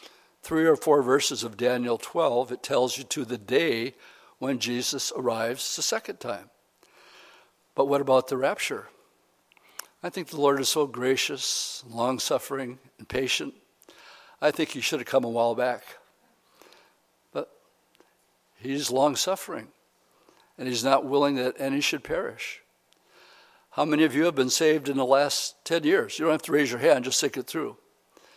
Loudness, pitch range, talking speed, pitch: -26 LUFS, 130-160 Hz, 165 wpm, 140 Hz